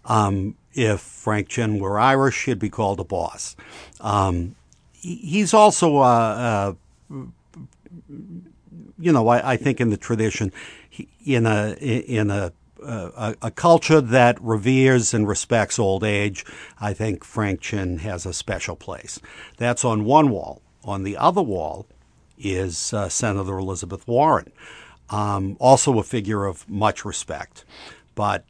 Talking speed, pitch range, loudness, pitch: 145 wpm, 100-125 Hz, -21 LUFS, 110 Hz